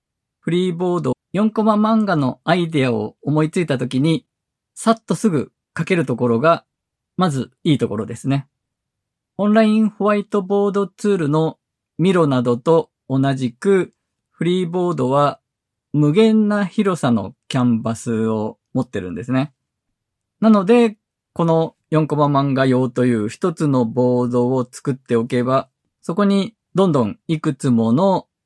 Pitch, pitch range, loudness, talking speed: 145 Hz, 125-185 Hz, -18 LUFS, 285 characters per minute